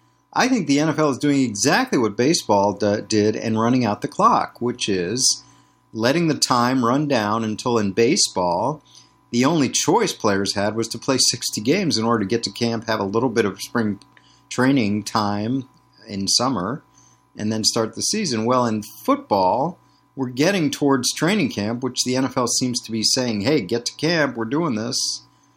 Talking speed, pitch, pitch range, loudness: 185 wpm, 120 Hz, 110-135 Hz, -20 LUFS